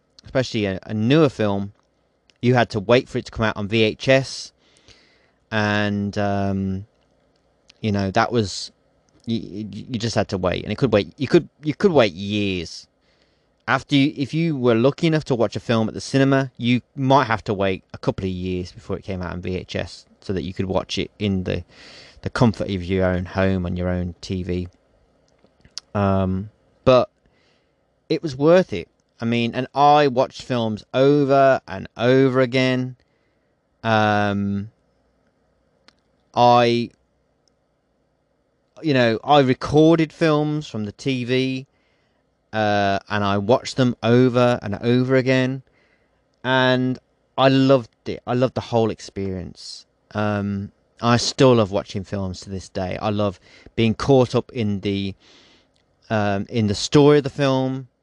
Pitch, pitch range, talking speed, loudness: 110 Hz, 100-130 Hz, 155 wpm, -20 LUFS